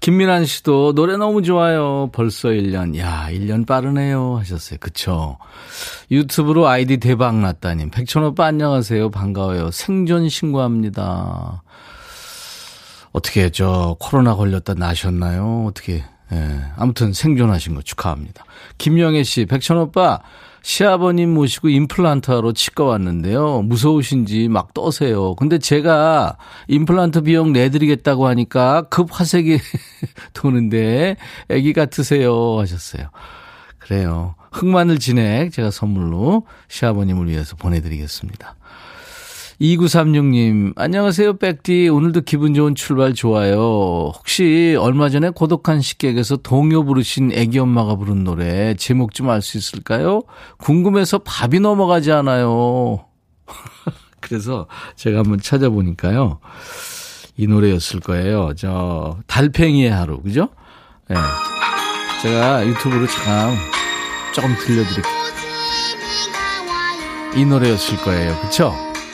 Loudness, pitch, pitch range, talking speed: -17 LUFS, 125 Hz, 100-155 Hz, 280 characters per minute